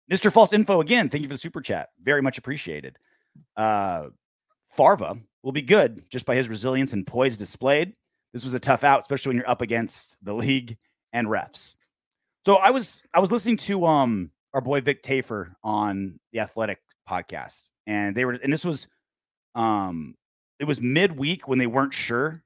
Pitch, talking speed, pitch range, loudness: 135 Hz, 185 wpm, 120-160 Hz, -24 LUFS